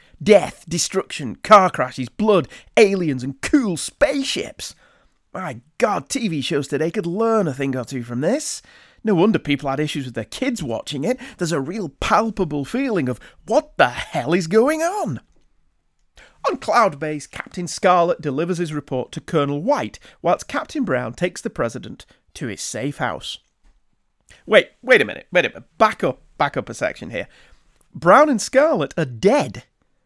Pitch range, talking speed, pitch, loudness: 145-225 Hz, 170 wpm, 175 Hz, -20 LUFS